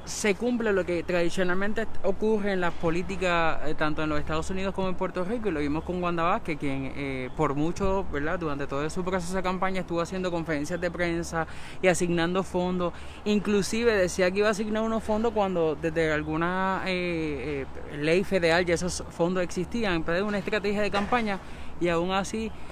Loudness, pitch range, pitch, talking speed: -28 LUFS, 165-195 Hz, 180 Hz, 185 wpm